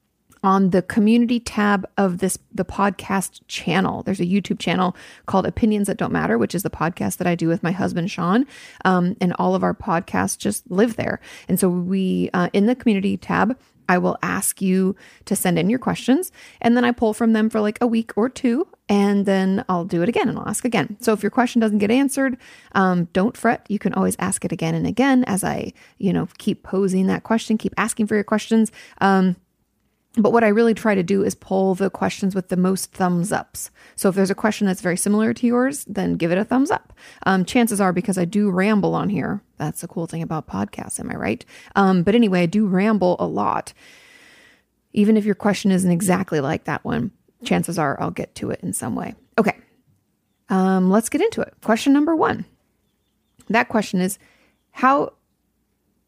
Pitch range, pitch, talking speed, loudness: 185-225 Hz, 200 Hz, 210 wpm, -20 LUFS